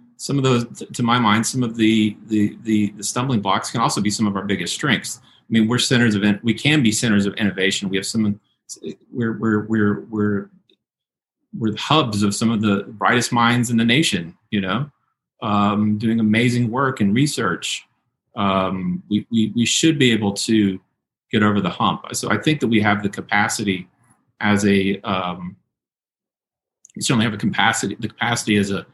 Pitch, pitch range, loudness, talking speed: 110 Hz, 100-120 Hz, -19 LUFS, 195 wpm